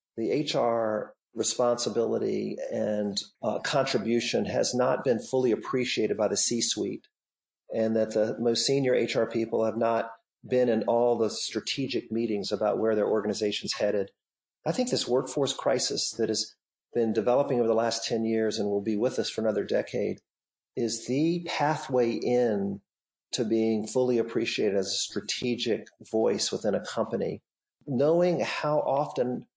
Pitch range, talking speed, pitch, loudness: 110-125 Hz, 150 wpm, 115 Hz, -28 LUFS